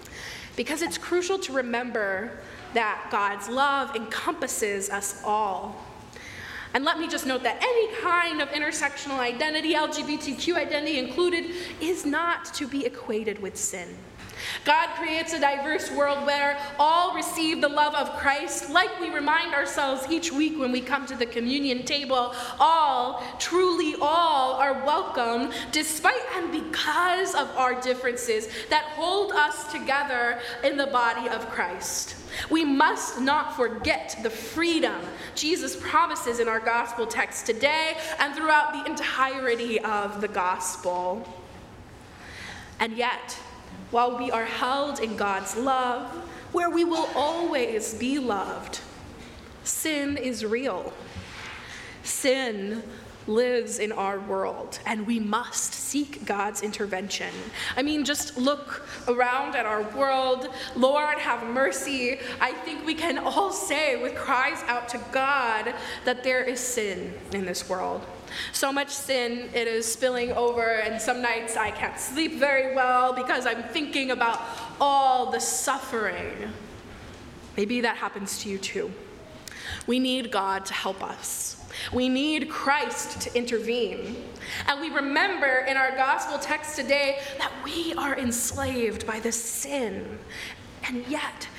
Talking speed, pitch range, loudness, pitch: 140 wpm, 235-300 Hz, -26 LUFS, 265 Hz